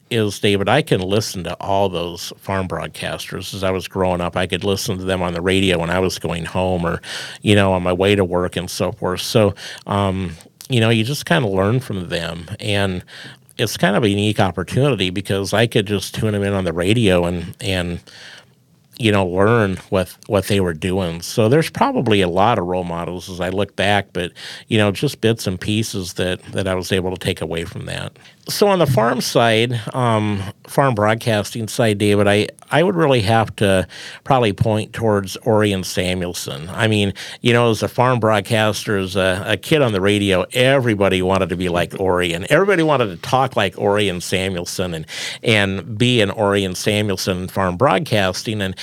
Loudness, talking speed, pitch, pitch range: -18 LUFS, 205 wpm, 100 Hz, 95-110 Hz